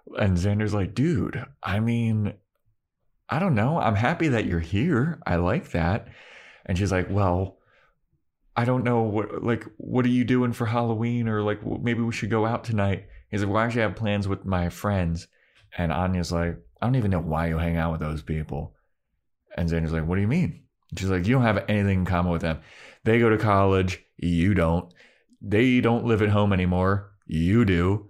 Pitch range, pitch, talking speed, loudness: 90-115 Hz, 100 Hz, 205 wpm, -25 LUFS